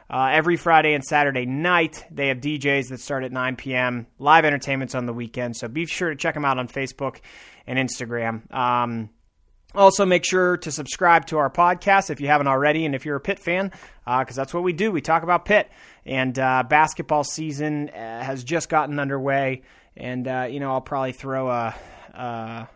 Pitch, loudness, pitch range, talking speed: 140 Hz, -22 LUFS, 130-160 Hz, 205 wpm